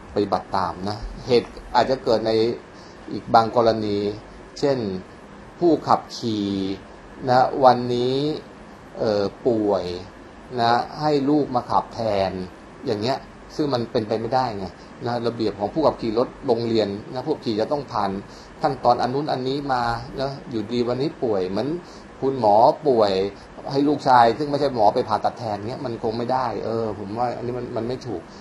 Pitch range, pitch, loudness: 105-130 Hz, 115 Hz, -22 LUFS